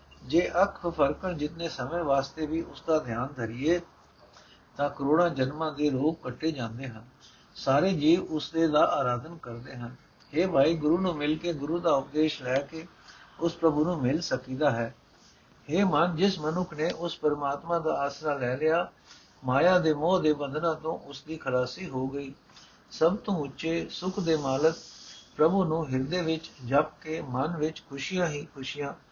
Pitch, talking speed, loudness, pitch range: 155 Hz, 165 wpm, -28 LUFS, 135-165 Hz